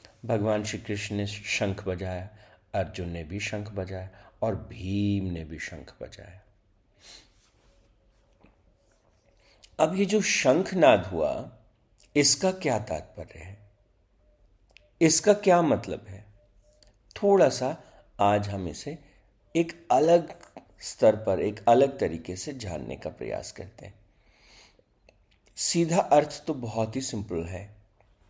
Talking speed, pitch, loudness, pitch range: 120 wpm, 105 Hz, -26 LUFS, 100-115 Hz